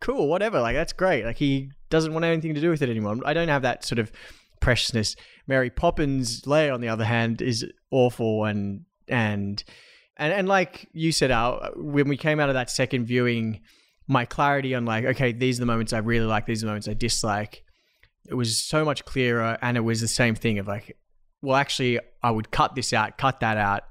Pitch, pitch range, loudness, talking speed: 120 Hz, 115-140 Hz, -24 LUFS, 220 wpm